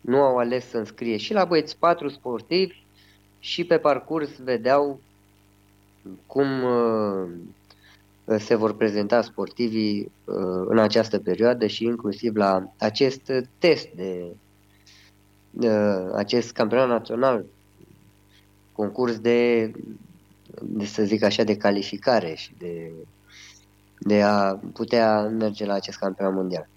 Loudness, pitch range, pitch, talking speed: -23 LUFS, 100-120 Hz, 105 Hz, 115 wpm